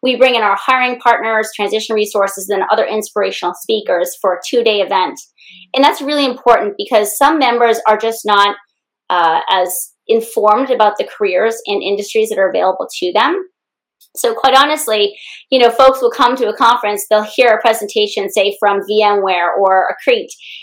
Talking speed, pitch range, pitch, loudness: 170 wpm, 205-255 Hz, 220 Hz, -13 LUFS